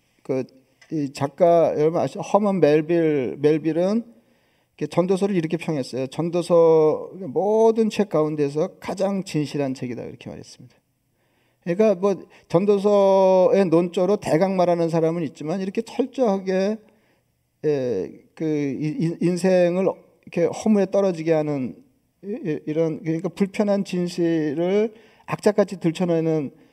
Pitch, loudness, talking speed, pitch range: 170 Hz, -22 LUFS, 280 characters per minute, 150-195 Hz